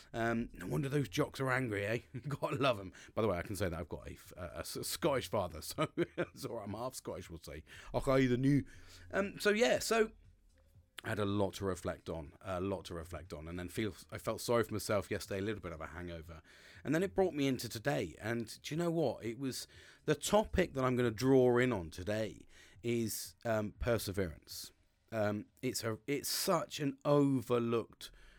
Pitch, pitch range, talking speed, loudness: 110 Hz, 90-130 Hz, 215 wpm, -36 LUFS